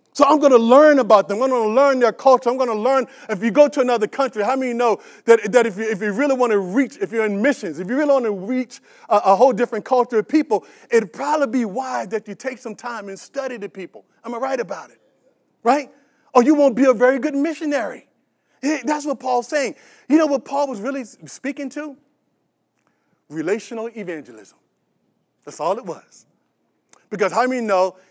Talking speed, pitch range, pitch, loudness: 205 wpm, 220-280 Hz, 255 Hz, -19 LUFS